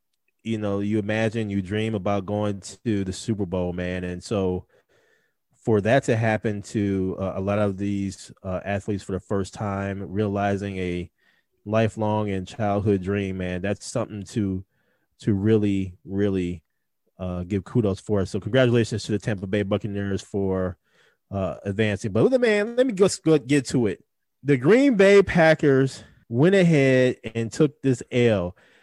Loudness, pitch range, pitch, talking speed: -23 LUFS, 100-115 Hz, 105 Hz, 160 wpm